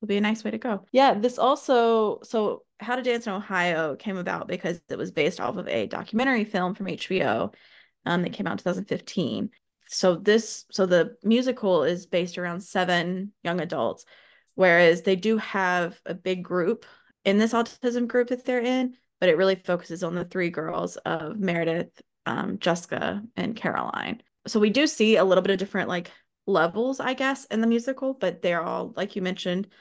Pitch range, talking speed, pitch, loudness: 180-235 Hz, 190 wpm, 200 Hz, -25 LUFS